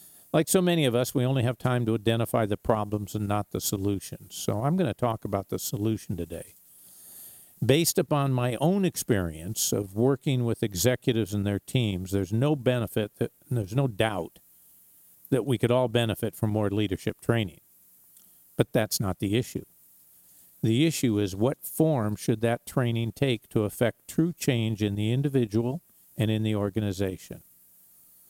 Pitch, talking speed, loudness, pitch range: 110 Hz, 170 wpm, -27 LUFS, 100-125 Hz